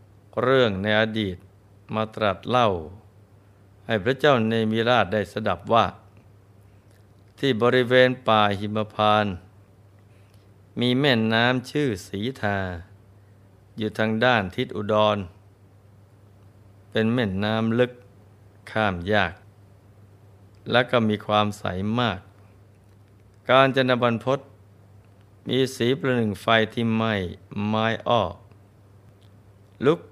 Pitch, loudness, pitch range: 105 Hz, -23 LUFS, 100-115 Hz